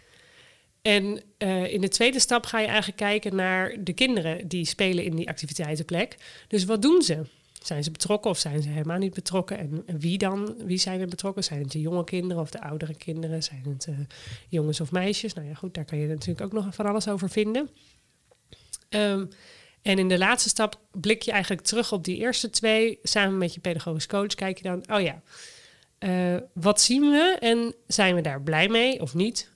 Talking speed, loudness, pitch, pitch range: 210 wpm, -25 LUFS, 190 Hz, 165-215 Hz